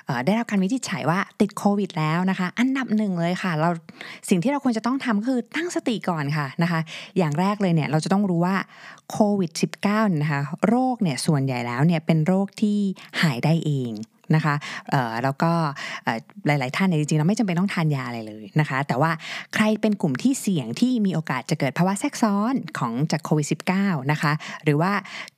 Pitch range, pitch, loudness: 155-210 Hz, 180 Hz, -23 LUFS